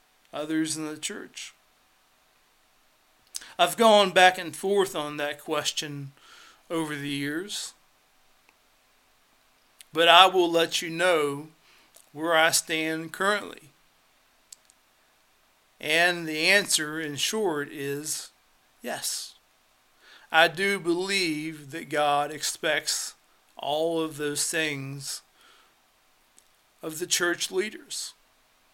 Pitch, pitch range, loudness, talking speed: 160 Hz, 150-175 Hz, -25 LUFS, 95 wpm